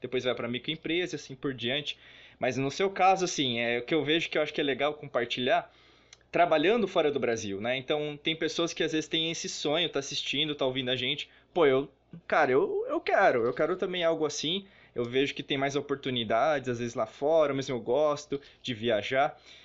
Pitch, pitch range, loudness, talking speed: 145 Hz, 130-165 Hz, -29 LUFS, 215 wpm